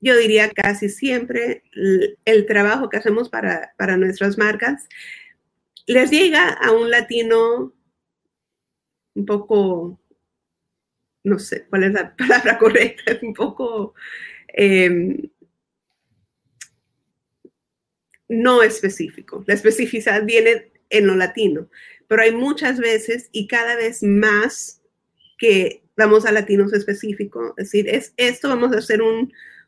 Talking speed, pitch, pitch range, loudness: 120 wpm, 220 Hz, 205-245 Hz, -17 LUFS